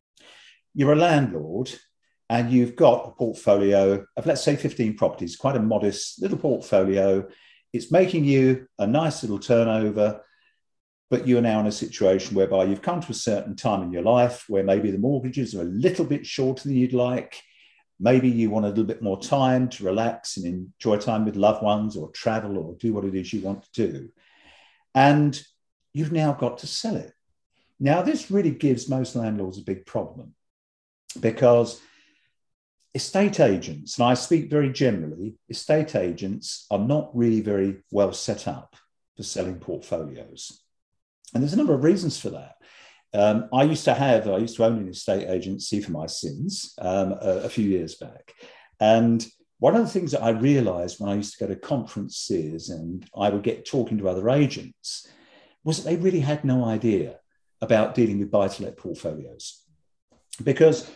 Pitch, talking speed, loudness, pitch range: 115 Hz, 180 wpm, -23 LUFS, 100-140 Hz